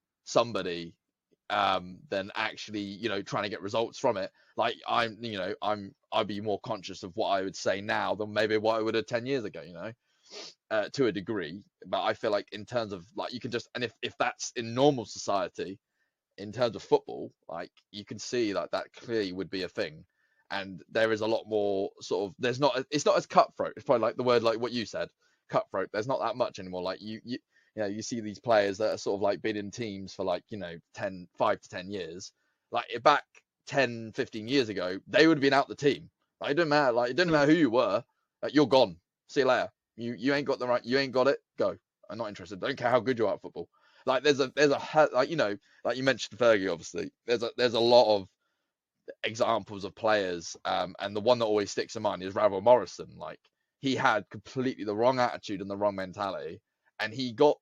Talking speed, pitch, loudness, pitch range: 240 wpm, 115 Hz, -29 LUFS, 100-135 Hz